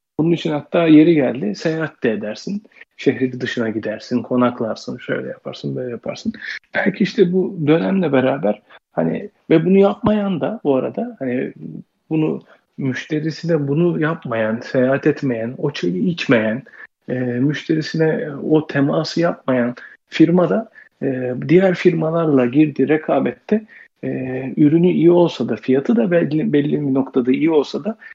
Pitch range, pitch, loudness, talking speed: 130-175 Hz, 155 Hz, -18 LUFS, 135 wpm